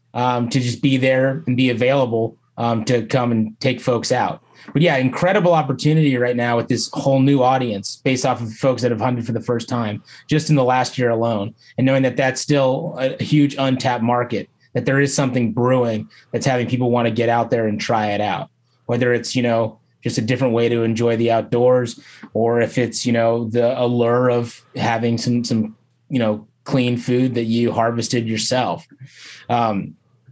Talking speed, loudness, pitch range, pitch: 200 wpm, -19 LUFS, 115-130 Hz, 125 Hz